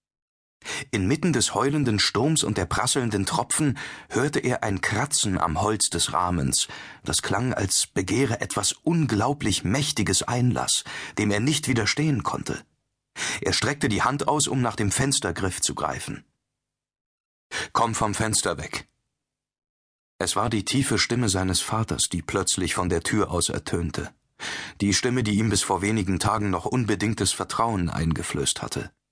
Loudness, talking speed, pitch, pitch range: -24 LUFS, 145 wpm, 105 Hz, 95-125 Hz